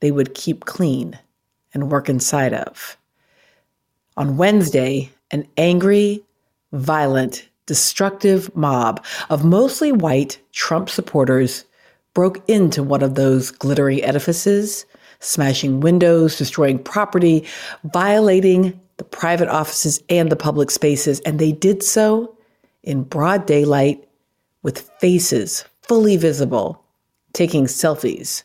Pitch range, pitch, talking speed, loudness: 140-185 Hz, 155 Hz, 110 wpm, -17 LUFS